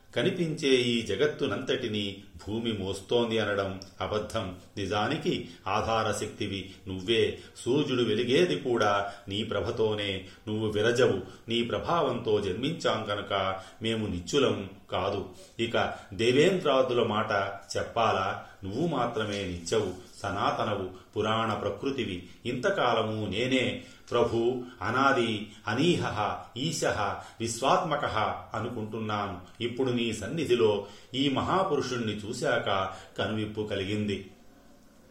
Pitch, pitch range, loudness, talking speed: 110 Hz, 100-120 Hz, -29 LUFS, 85 wpm